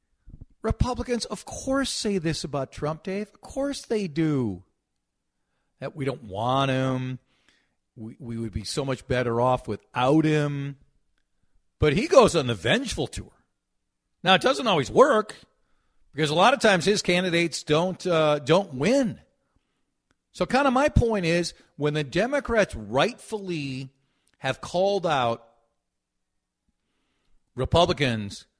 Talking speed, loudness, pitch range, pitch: 135 wpm, -24 LUFS, 130-190 Hz, 155 Hz